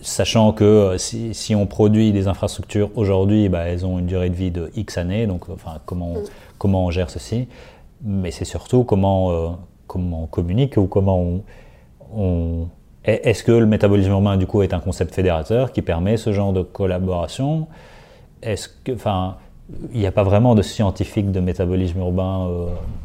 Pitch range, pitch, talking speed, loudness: 90-105 Hz, 95 Hz, 180 wpm, -20 LUFS